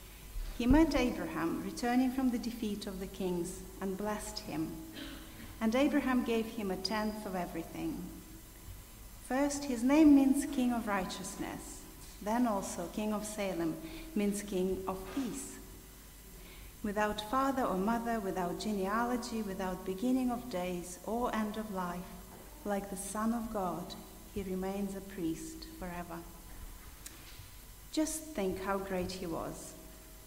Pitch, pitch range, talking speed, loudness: 200 Hz, 180-230 Hz, 135 wpm, -35 LUFS